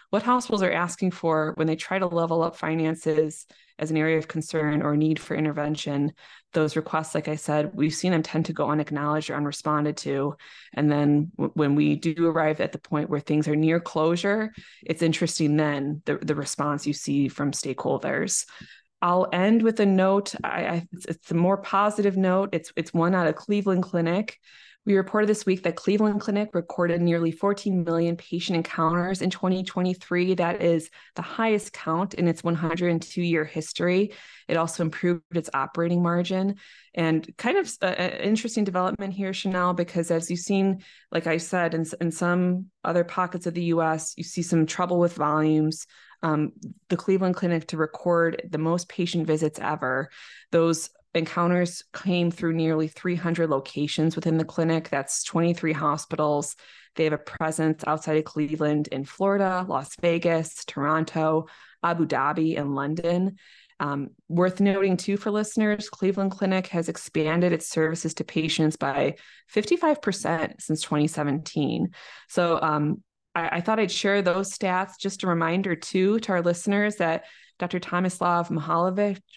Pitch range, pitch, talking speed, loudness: 155-185 Hz, 170 Hz, 165 wpm, -25 LUFS